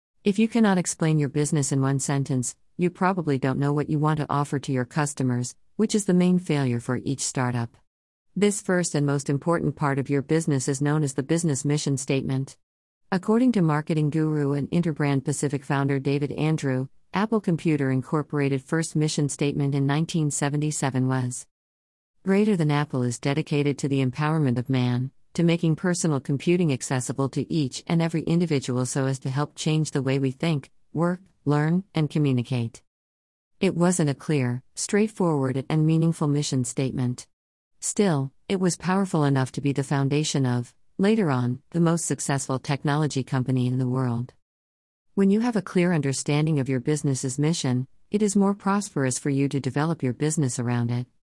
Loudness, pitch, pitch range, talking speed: -25 LUFS, 145 Hz, 130-165 Hz, 175 wpm